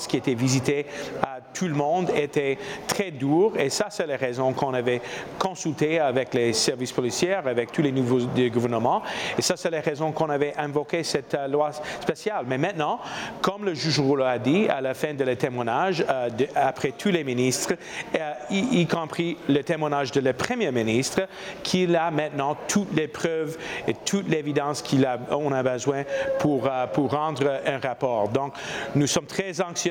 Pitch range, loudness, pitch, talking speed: 130-165 Hz, -25 LUFS, 145 Hz, 175 wpm